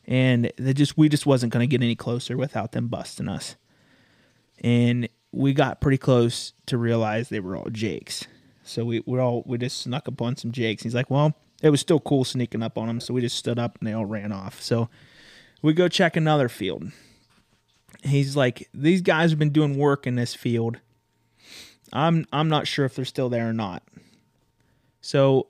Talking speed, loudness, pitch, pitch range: 200 wpm, -24 LUFS, 125 Hz, 115-140 Hz